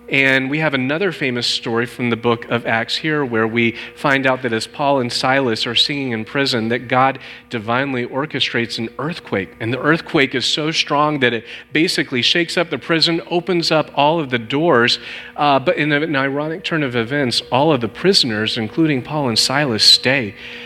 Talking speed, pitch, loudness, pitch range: 195 wpm, 135 Hz, -17 LUFS, 120-150 Hz